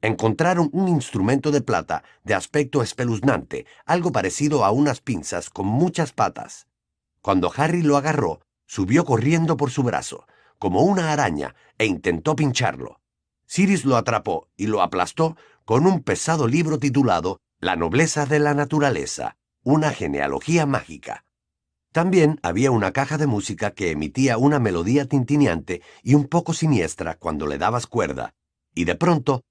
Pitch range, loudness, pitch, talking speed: 110-155 Hz, -21 LUFS, 140 Hz, 145 wpm